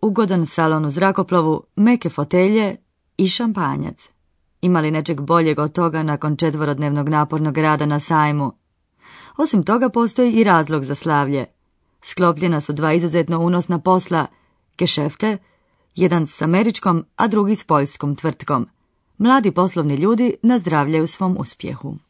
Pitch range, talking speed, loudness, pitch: 155-195 Hz, 130 wpm, -18 LUFS, 170 Hz